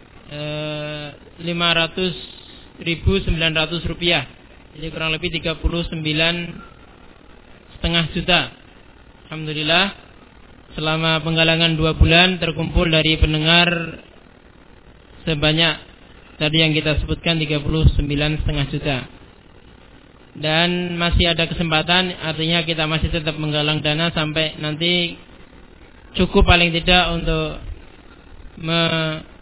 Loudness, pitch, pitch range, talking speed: -18 LUFS, 160 Hz, 150-170 Hz, 85 wpm